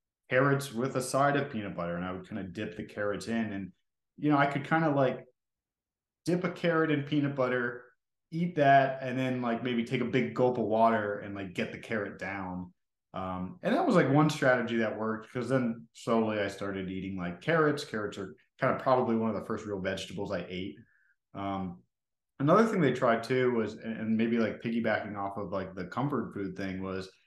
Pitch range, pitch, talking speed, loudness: 100-135 Hz, 115 Hz, 215 wpm, -30 LUFS